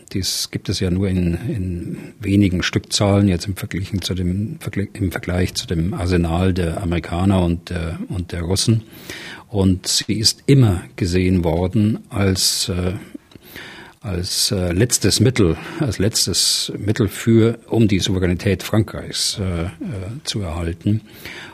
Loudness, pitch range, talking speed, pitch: -19 LUFS, 90-105 Hz, 130 wpm, 95 Hz